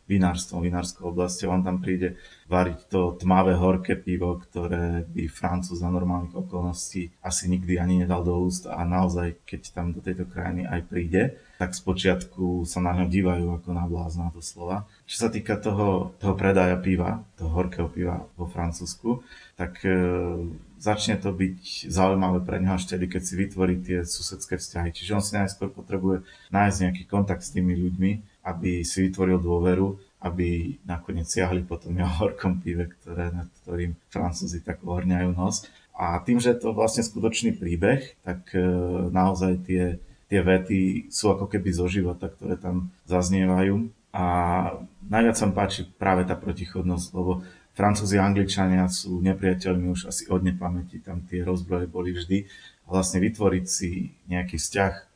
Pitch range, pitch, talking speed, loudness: 90-95 Hz, 90 Hz, 165 wpm, -26 LUFS